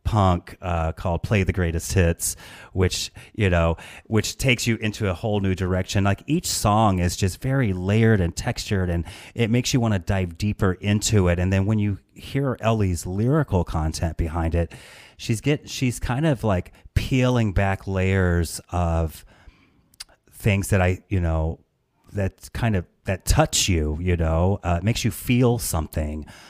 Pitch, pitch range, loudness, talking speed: 95 Hz, 85-110 Hz, -23 LUFS, 170 wpm